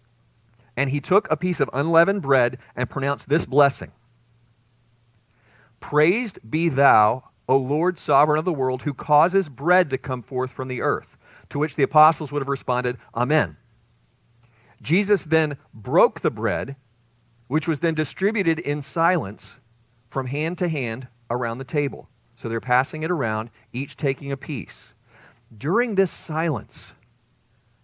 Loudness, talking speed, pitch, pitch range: -22 LUFS, 145 wpm, 135 Hz, 120-155 Hz